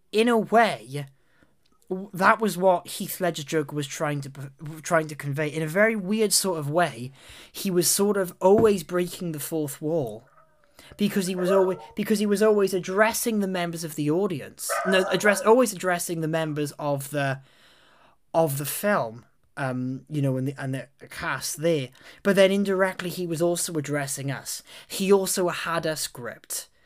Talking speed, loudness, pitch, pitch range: 175 wpm, -25 LUFS, 175 Hz, 150-195 Hz